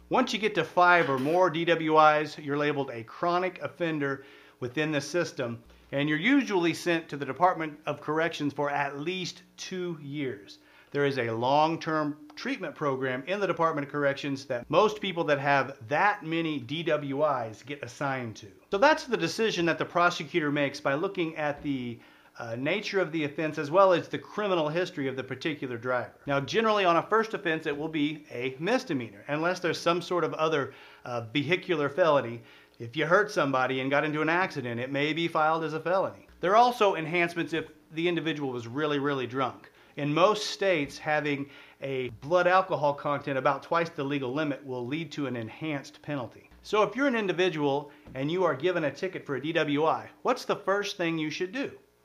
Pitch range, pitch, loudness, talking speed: 140-175 Hz, 155 Hz, -28 LUFS, 195 wpm